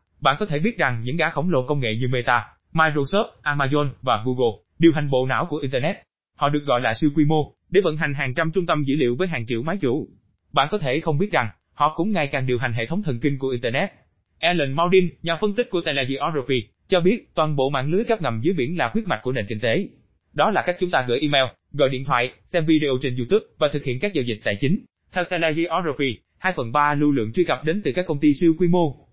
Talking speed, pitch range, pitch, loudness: 260 wpm, 130-170 Hz, 150 Hz, -22 LUFS